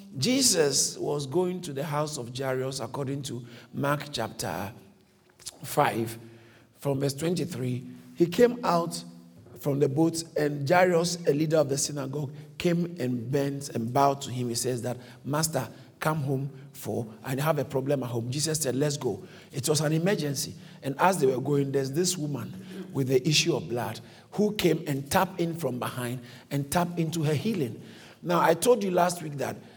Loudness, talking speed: -28 LUFS, 180 wpm